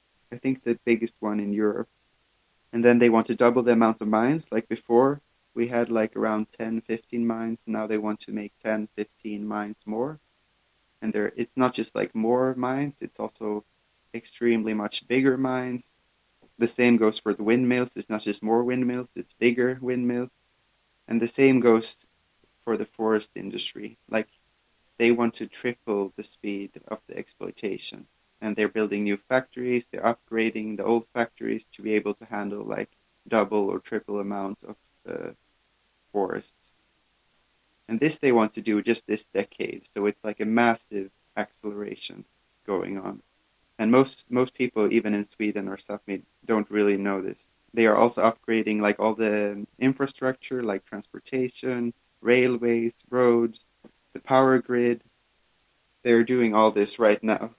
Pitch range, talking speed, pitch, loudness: 105-120 Hz, 155 wpm, 115 Hz, -26 LUFS